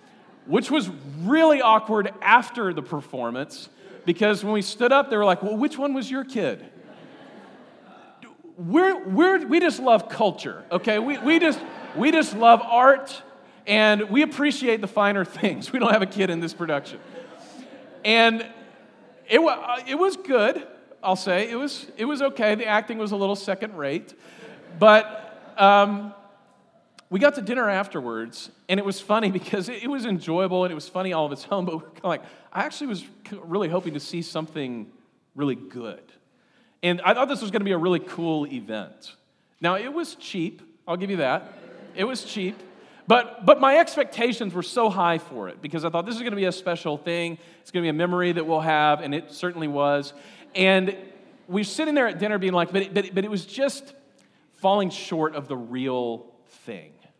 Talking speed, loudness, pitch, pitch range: 190 wpm, -23 LUFS, 200 Hz, 170-245 Hz